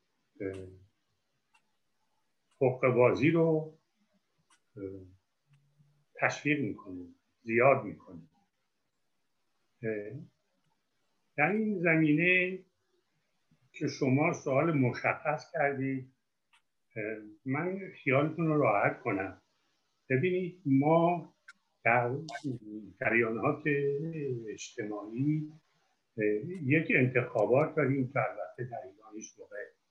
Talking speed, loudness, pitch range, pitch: 65 wpm, -30 LUFS, 115-155 Hz, 140 Hz